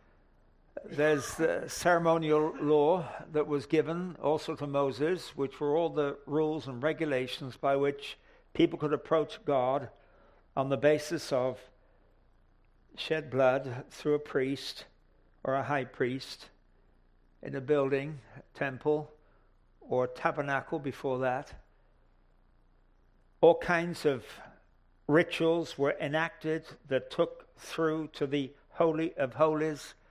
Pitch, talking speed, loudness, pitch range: 145 Hz, 120 wpm, -31 LUFS, 130-160 Hz